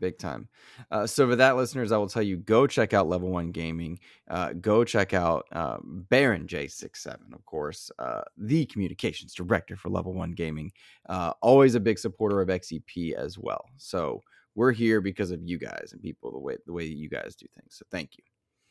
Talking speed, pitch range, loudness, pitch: 205 wpm, 90-115 Hz, -27 LUFS, 100 Hz